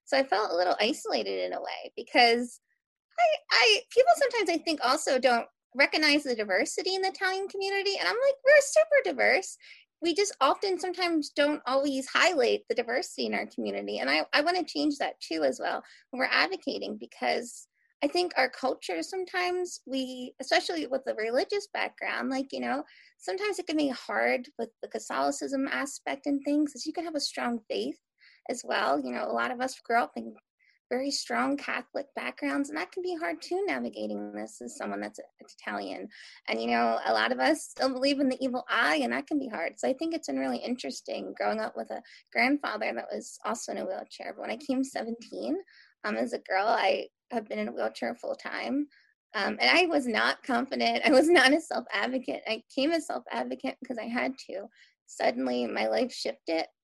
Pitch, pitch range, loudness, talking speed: 280 Hz, 245-345 Hz, -28 LUFS, 205 wpm